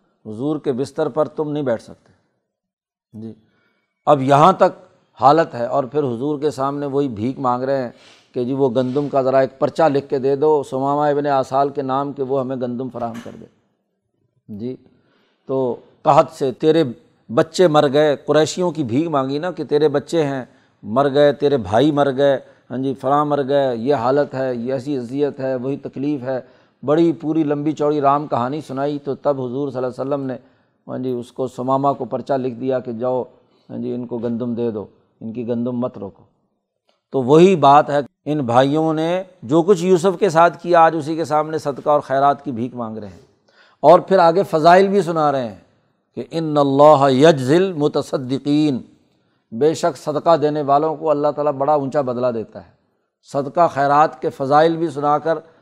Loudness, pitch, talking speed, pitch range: -18 LUFS, 140 Hz, 195 wpm, 130-155 Hz